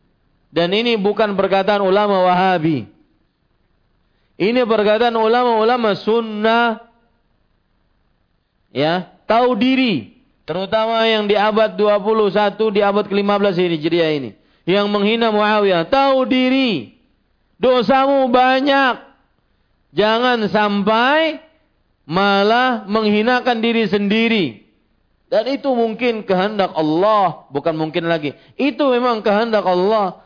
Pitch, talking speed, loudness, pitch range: 210 Hz, 95 wpm, -16 LUFS, 185-235 Hz